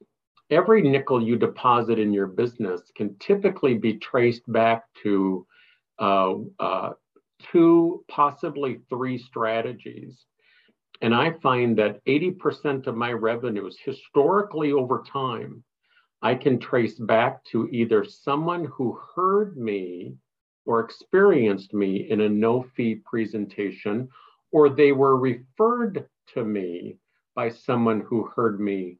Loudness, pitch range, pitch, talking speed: -23 LUFS, 110-145 Hz, 120 Hz, 120 wpm